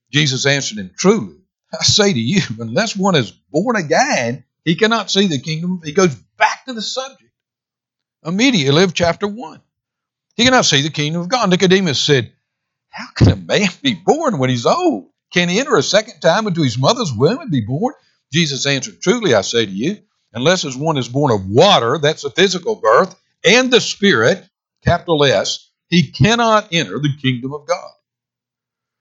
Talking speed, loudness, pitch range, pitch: 185 wpm, -15 LUFS, 145-210 Hz, 175 Hz